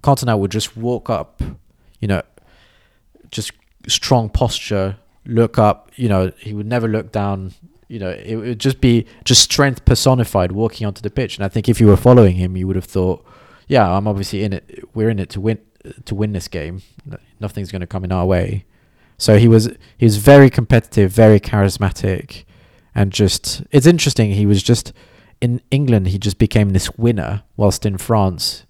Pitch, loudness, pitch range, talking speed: 110 Hz, -16 LUFS, 100-120 Hz, 190 wpm